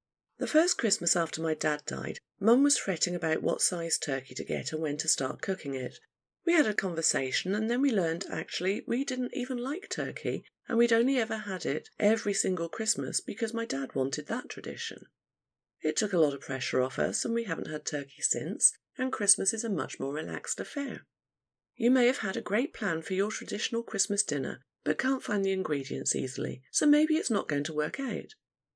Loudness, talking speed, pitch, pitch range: -30 LUFS, 205 wpm, 205 Hz, 160-245 Hz